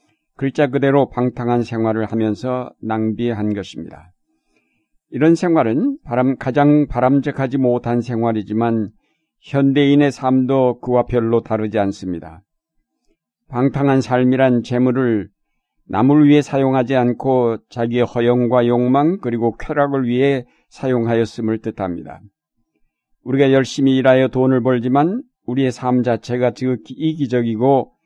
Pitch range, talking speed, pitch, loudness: 115-135 Hz, 285 characters per minute, 125 Hz, -17 LUFS